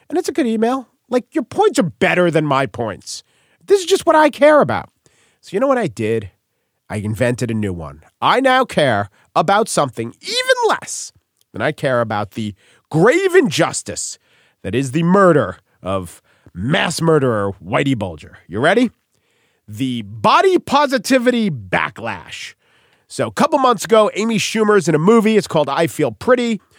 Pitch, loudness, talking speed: 180 Hz, -16 LUFS, 170 wpm